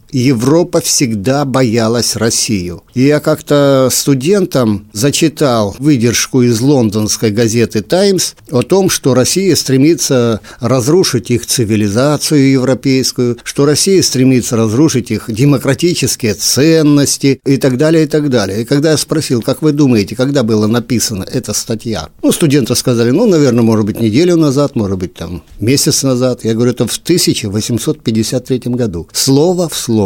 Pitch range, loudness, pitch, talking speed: 115-145 Hz, -11 LUFS, 130 Hz, 140 wpm